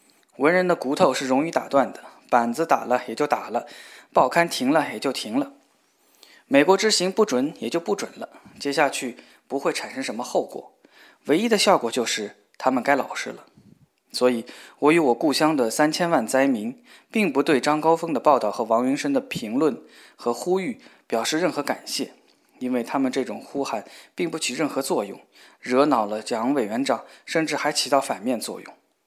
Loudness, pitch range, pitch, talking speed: -23 LUFS, 130-195 Hz, 150 Hz, 270 characters per minute